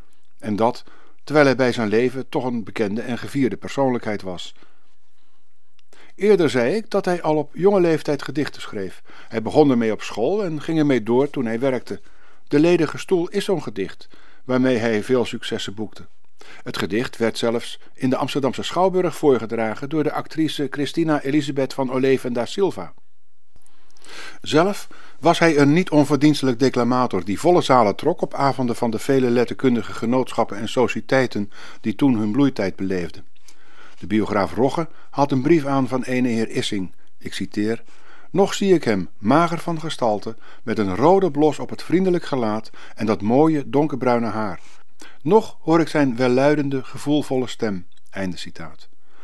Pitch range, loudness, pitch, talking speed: 115-150 Hz, -21 LUFS, 130 Hz, 160 wpm